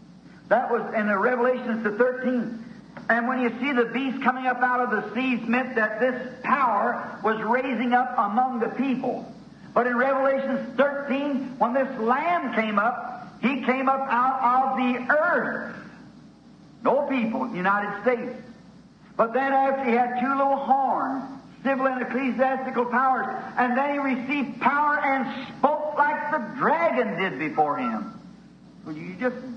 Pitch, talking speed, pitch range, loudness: 250 Hz, 155 wpm, 235-265 Hz, -24 LUFS